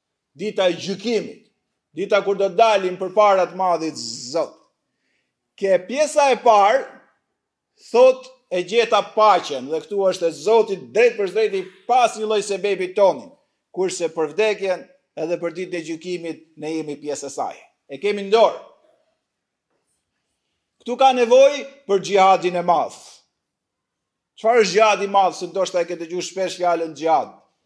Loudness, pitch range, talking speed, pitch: -19 LUFS, 175-230 Hz, 145 wpm, 195 Hz